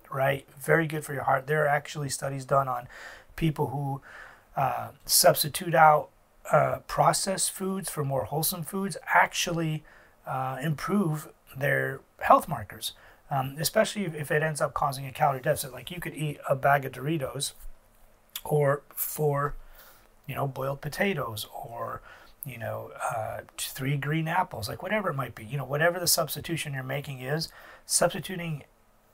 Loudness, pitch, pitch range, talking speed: -28 LUFS, 150 Hz, 135-165 Hz, 155 wpm